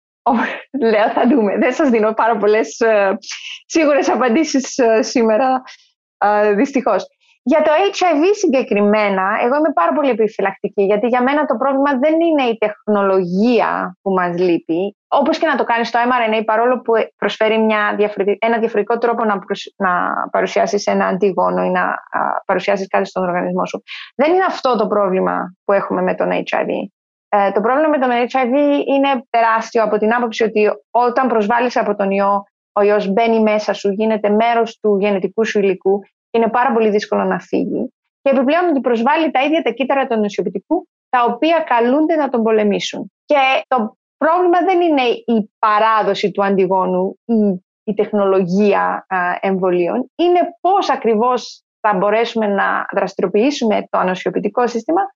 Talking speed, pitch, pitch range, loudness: 160 wpm, 225 Hz, 205-270 Hz, -16 LUFS